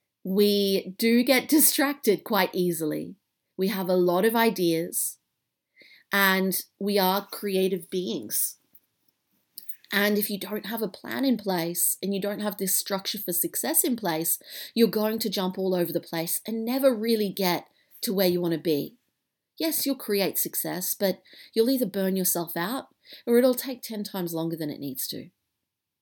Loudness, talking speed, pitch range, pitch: -25 LUFS, 170 wpm, 175-225 Hz, 195 Hz